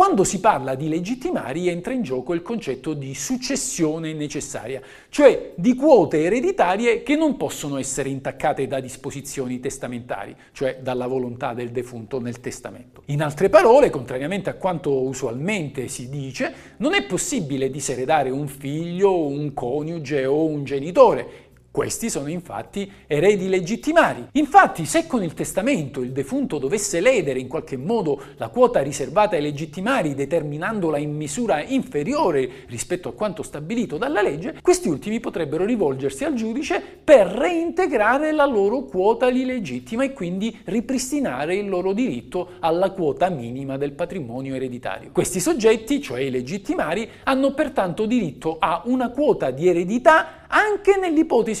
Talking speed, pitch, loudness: 145 wpm, 175 Hz, -21 LUFS